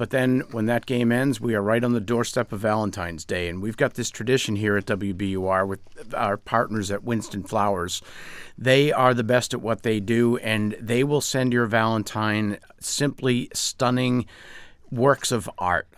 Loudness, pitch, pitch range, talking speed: -24 LUFS, 115 Hz, 105-125 Hz, 180 wpm